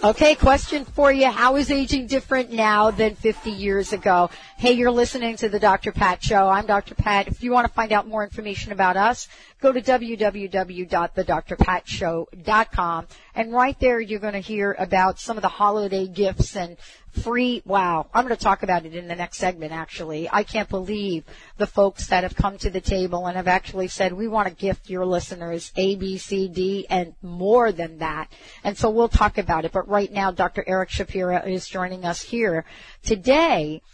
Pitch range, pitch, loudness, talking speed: 185-225 Hz, 200 Hz, -22 LUFS, 195 wpm